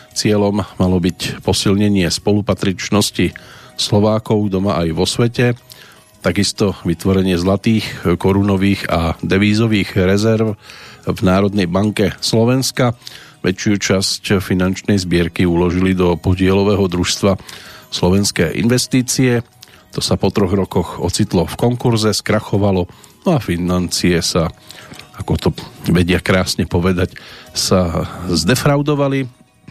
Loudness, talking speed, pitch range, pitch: -16 LUFS, 105 wpm, 90-110 Hz, 100 Hz